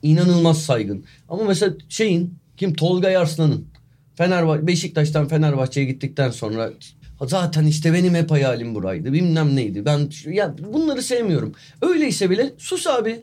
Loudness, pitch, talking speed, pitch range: -20 LUFS, 160 Hz, 130 wpm, 140-180 Hz